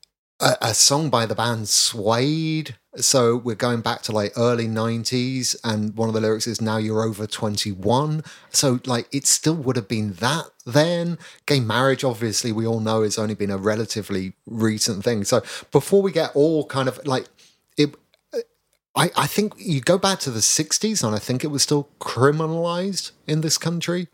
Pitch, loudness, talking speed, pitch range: 125 Hz, -21 LUFS, 185 wpm, 110-155 Hz